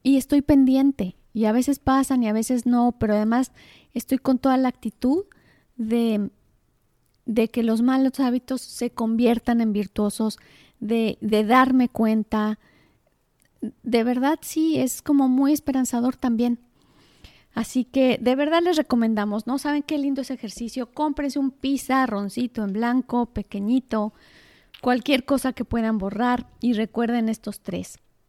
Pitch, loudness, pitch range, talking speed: 245 Hz, -23 LUFS, 225-265 Hz, 145 wpm